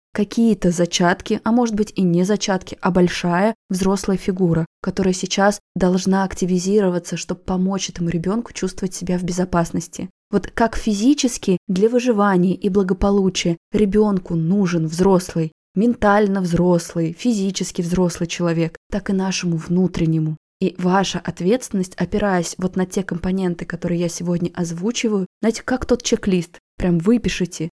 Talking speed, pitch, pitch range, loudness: 130 wpm, 185 Hz, 175-205 Hz, -20 LUFS